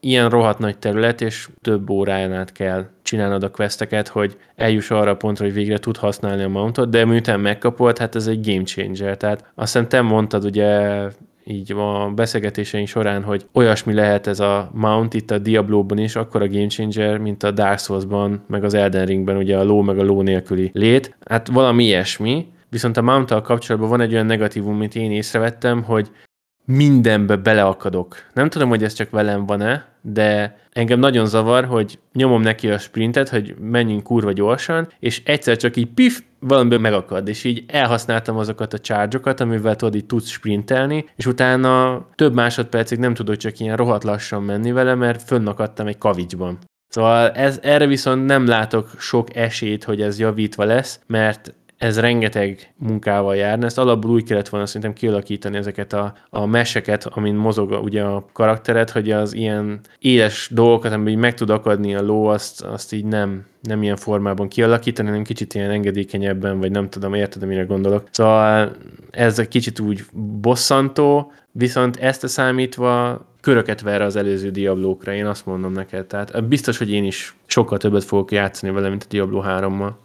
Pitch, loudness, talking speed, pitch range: 110 Hz, -18 LUFS, 180 wpm, 100-120 Hz